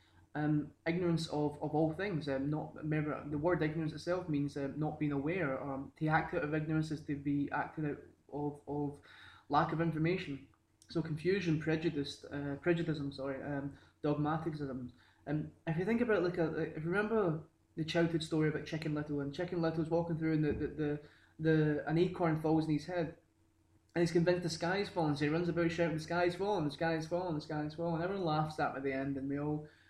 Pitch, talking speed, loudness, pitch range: 155 Hz, 215 wpm, -36 LUFS, 145-165 Hz